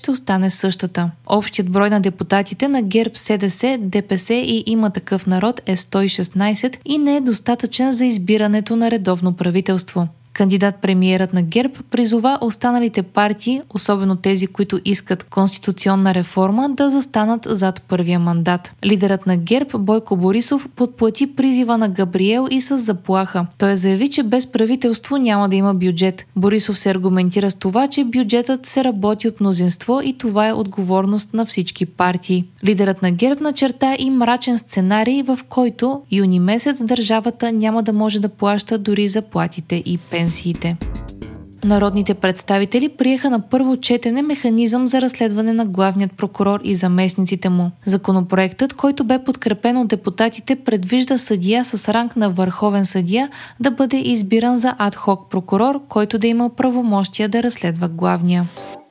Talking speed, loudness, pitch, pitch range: 150 wpm, -16 LUFS, 210 Hz, 190-245 Hz